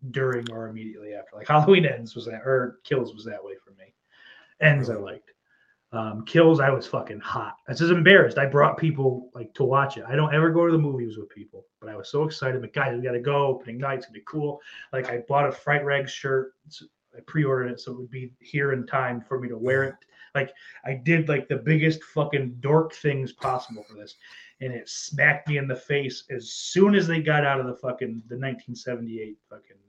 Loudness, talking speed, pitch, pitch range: -24 LUFS, 235 wpm, 135 Hz, 125-150 Hz